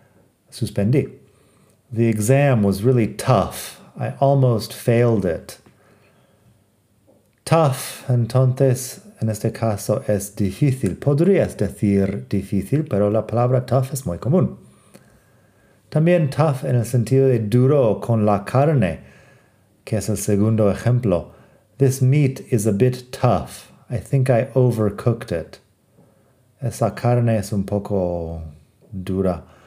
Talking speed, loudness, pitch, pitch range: 120 wpm, -20 LUFS, 115 Hz, 105-130 Hz